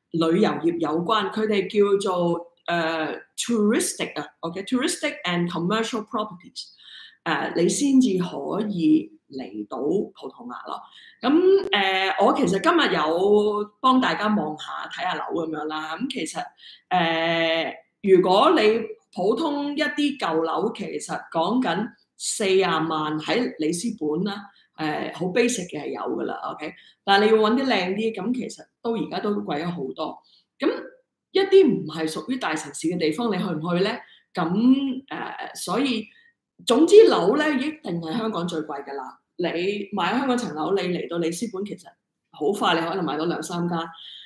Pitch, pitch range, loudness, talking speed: 205 Hz, 170-250 Hz, -23 LUFS, 295 characters per minute